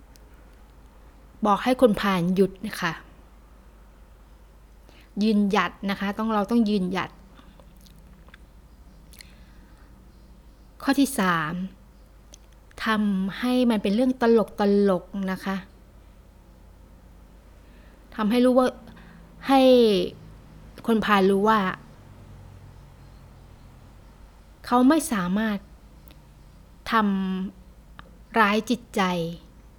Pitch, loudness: 180 Hz, -23 LUFS